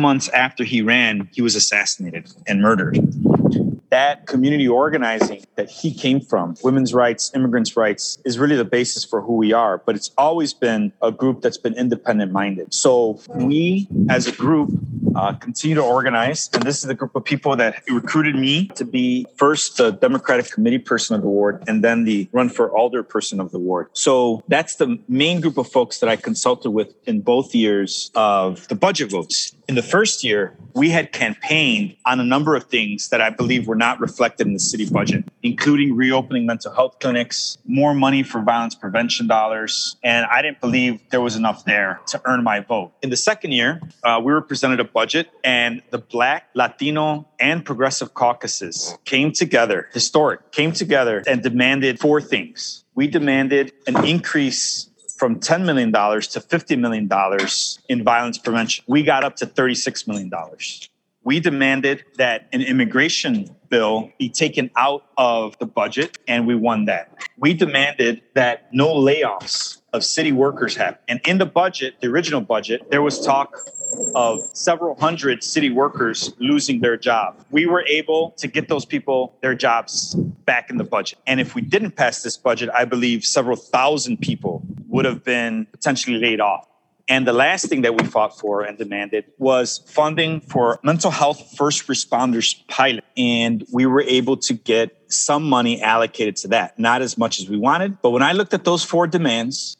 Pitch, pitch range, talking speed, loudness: 135 Hz, 120-155 Hz, 180 wpm, -19 LUFS